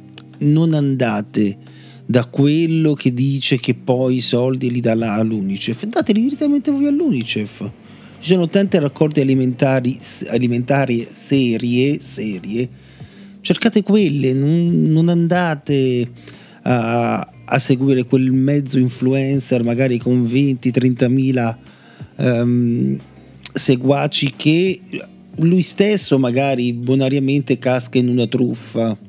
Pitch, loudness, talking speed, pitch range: 130 Hz, -17 LUFS, 105 wpm, 120-150 Hz